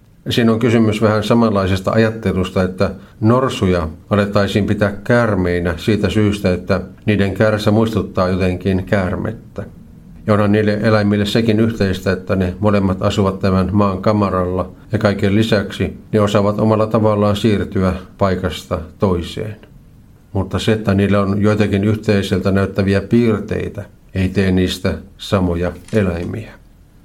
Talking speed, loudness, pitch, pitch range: 125 wpm, -16 LUFS, 100 Hz, 95-110 Hz